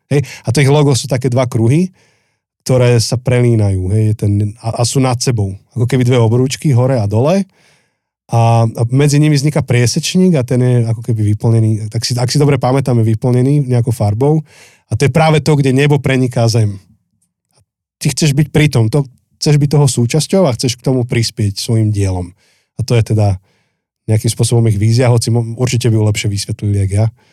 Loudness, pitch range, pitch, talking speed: -13 LUFS, 110-140 Hz, 120 Hz, 195 wpm